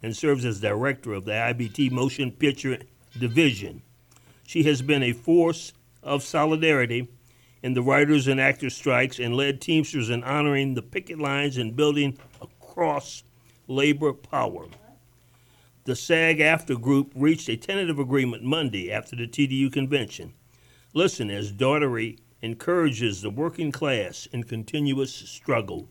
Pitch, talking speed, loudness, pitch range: 135 Hz, 135 wpm, -24 LUFS, 120-145 Hz